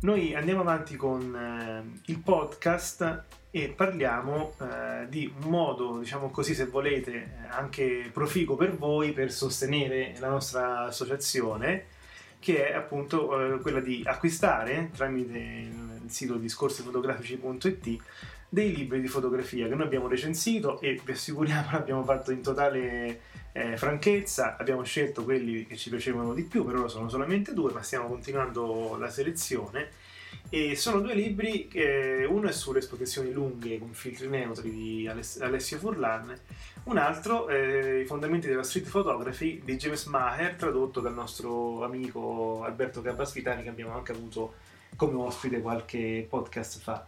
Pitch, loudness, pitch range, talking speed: 130 Hz, -30 LUFS, 120-150 Hz, 145 wpm